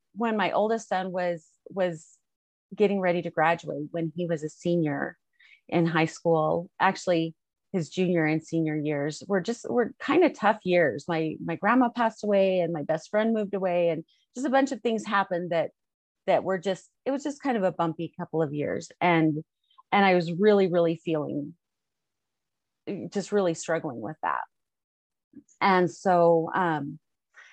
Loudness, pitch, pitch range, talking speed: -26 LUFS, 175 Hz, 165-205 Hz, 170 wpm